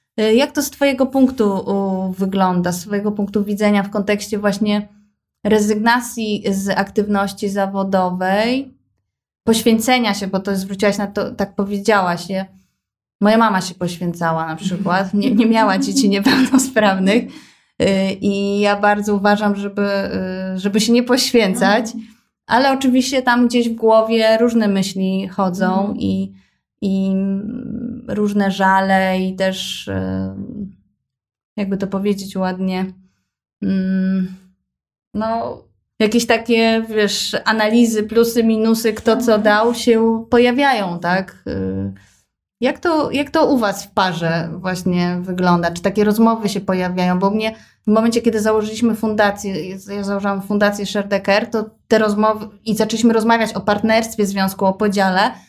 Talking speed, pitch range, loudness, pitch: 125 wpm, 190-225 Hz, -17 LUFS, 205 Hz